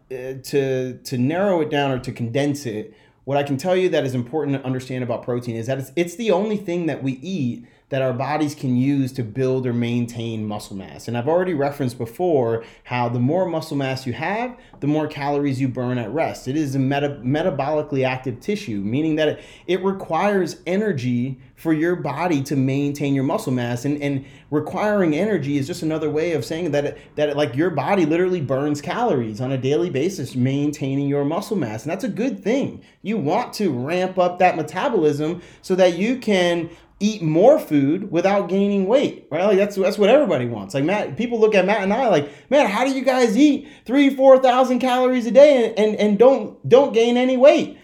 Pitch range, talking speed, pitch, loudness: 130-195 Hz, 210 wpm, 150 Hz, -20 LUFS